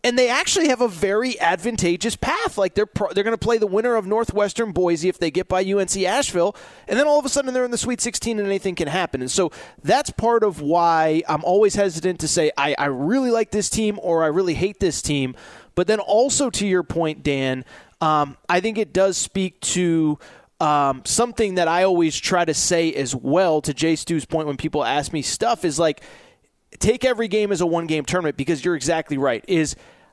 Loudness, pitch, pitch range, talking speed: -21 LUFS, 185 Hz, 160-215 Hz, 220 wpm